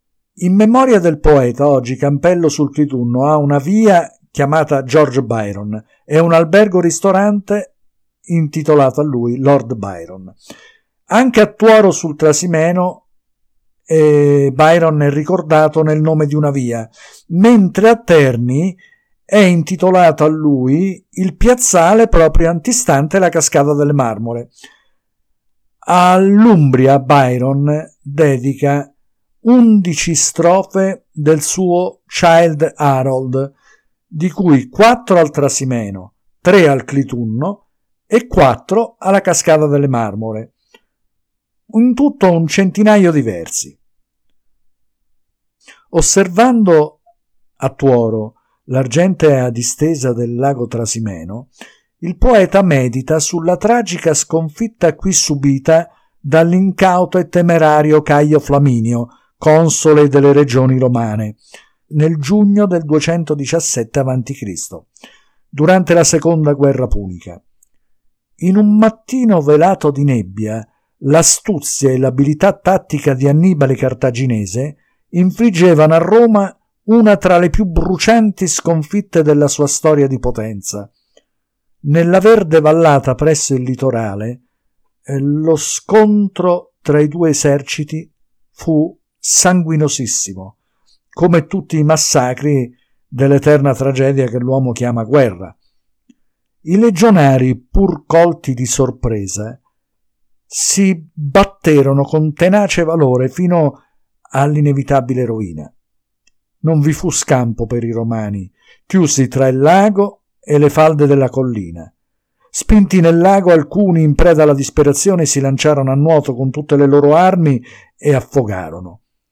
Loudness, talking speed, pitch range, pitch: -12 LUFS, 110 wpm, 130-180 Hz, 150 Hz